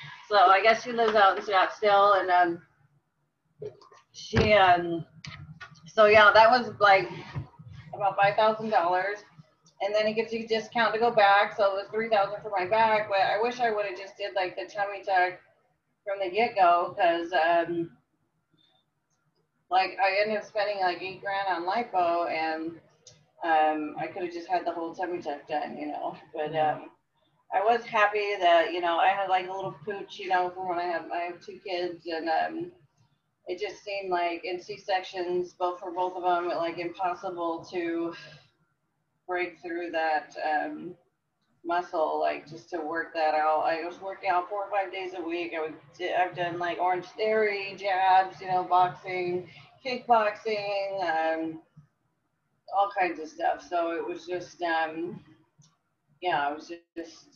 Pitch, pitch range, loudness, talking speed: 180 Hz, 165-200 Hz, -27 LUFS, 180 wpm